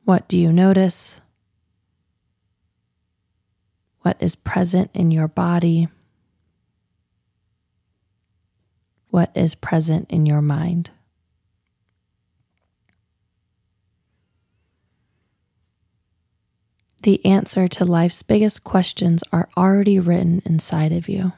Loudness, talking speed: -18 LUFS, 80 wpm